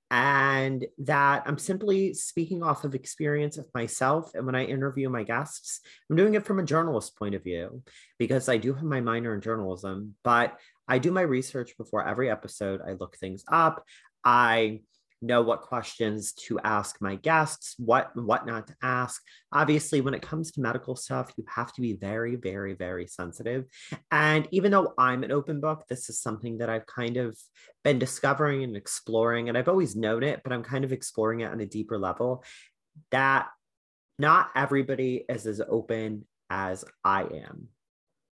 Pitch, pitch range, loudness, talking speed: 125 Hz, 110-140 Hz, -27 LUFS, 180 wpm